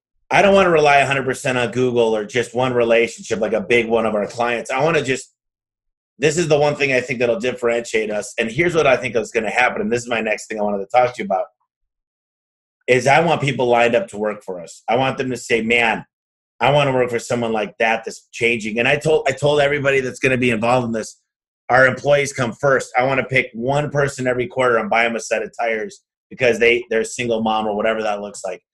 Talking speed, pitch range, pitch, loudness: 260 wpm, 110-135 Hz, 120 Hz, -18 LUFS